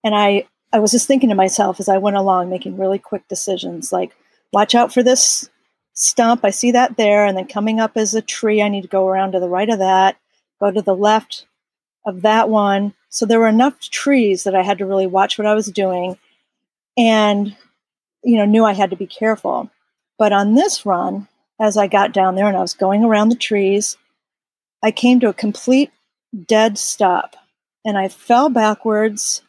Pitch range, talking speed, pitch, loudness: 195-225 Hz, 205 wpm, 210 Hz, -16 LUFS